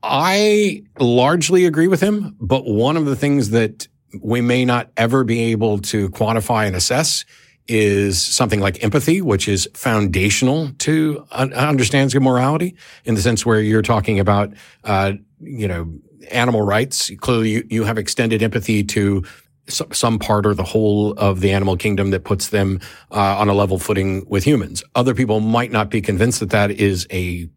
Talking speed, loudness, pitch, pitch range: 180 wpm, -17 LUFS, 110 Hz, 100-130 Hz